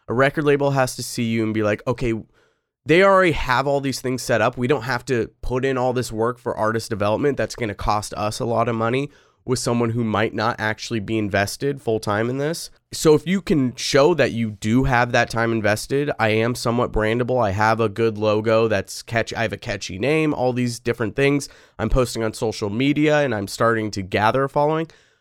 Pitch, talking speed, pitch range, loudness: 120 Hz, 225 wpm, 110-135 Hz, -21 LUFS